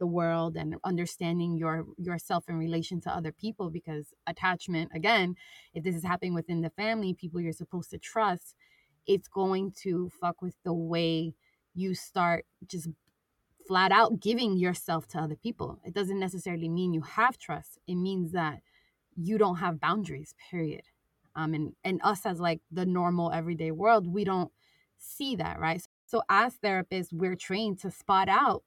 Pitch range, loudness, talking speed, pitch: 165-190 Hz, -30 LUFS, 170 wpm, 180 Hz